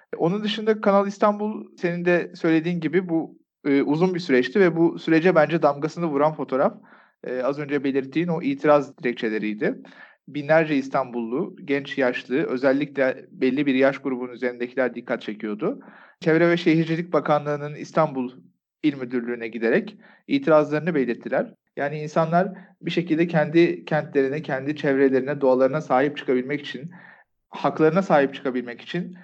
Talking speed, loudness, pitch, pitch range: 135 wpm, -23 LUFS, 150 Hz, 135-170 Hz